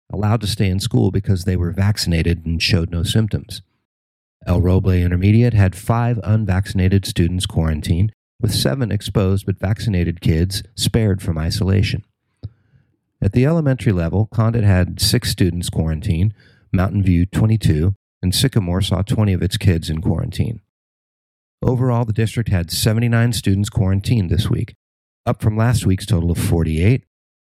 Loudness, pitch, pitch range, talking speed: -18 LUFS, 100 Hz, 90-115 Hz, 145 wpm